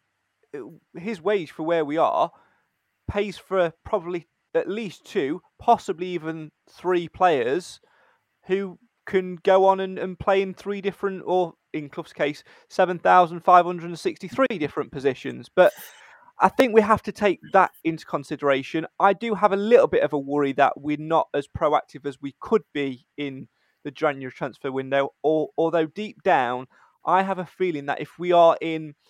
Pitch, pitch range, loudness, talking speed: 175 Hz, 150-200 Hz, -23 LUFS, 165 wpm